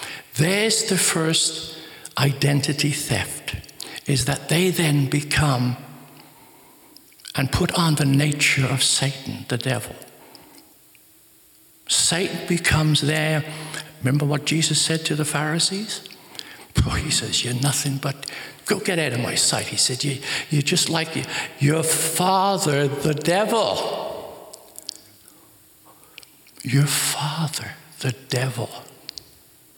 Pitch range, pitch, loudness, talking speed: 140-160 Hz, 150 Hz, -21 LUFS, 110 wpm